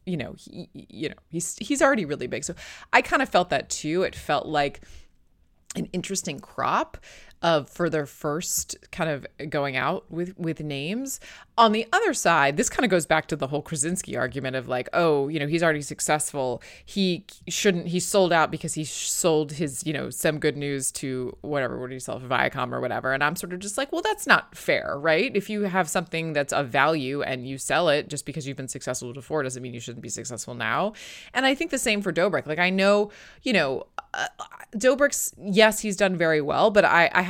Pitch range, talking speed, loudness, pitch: 140-200 Hz, 220 wpm, -25 LUFS, 160 Hz